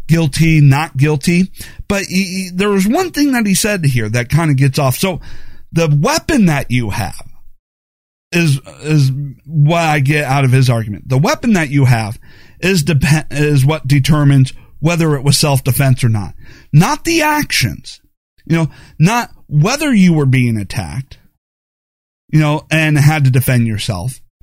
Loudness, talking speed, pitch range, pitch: -13 LUFS, 165 wpm, 130-170 Hz, 150 Hz